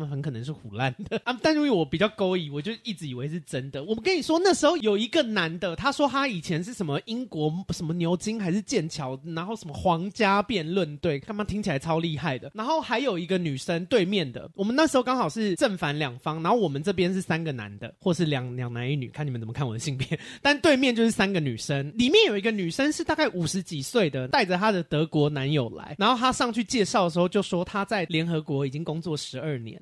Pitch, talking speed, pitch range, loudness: 180 Hz, 365 characters per minute, 150-220 Hz, -26 LUFS